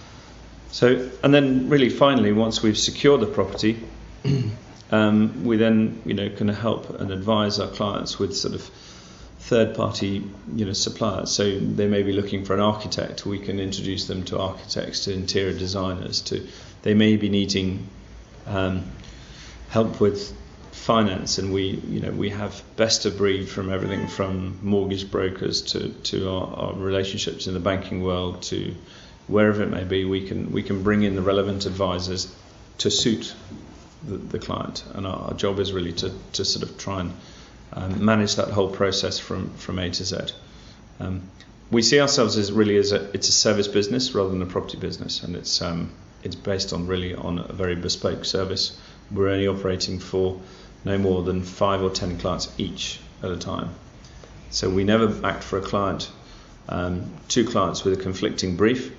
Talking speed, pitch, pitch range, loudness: 180 wpm, 100 Hz, 95-105 Hz, -23 LUFS